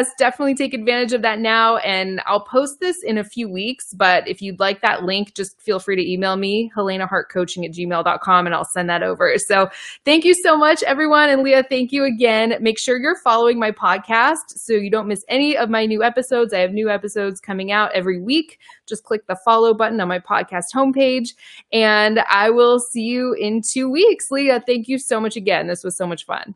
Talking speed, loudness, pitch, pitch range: 215 wpm, -18 LUFS, 225 Hz, 195-255 Hz